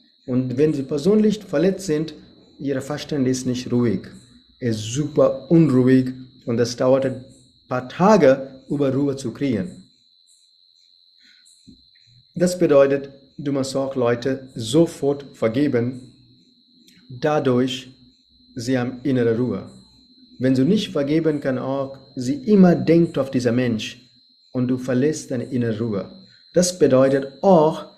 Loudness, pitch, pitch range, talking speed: -20 LUFS, 135 Hz, 125-155 Hz, 125 wpm